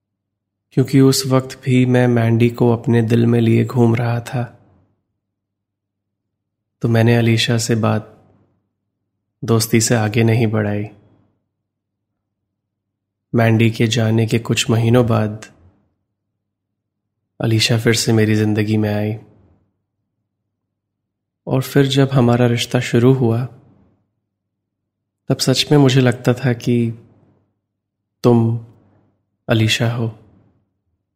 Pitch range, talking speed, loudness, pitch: 100-120 Hz, 105 wpm, -16 LUFS, 110 Hz